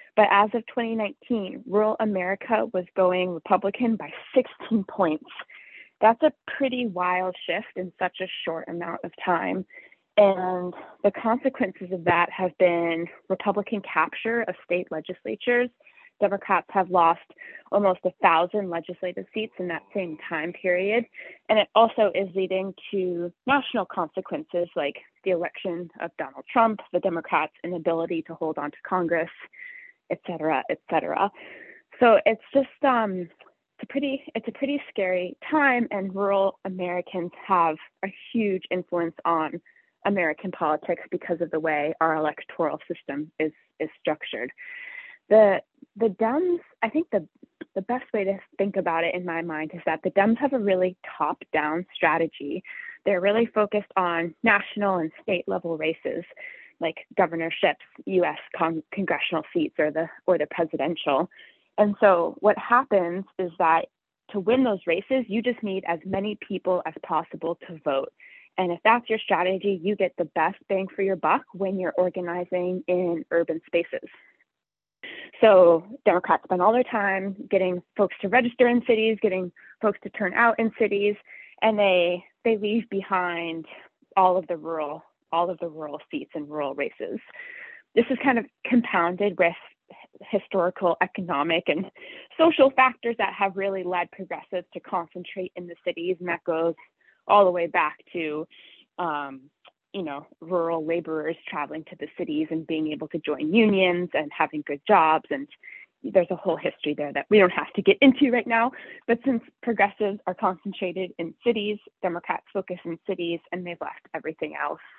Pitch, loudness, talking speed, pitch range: 190 Hz, -25 LUFS, 160 wpm, 170-225 Hz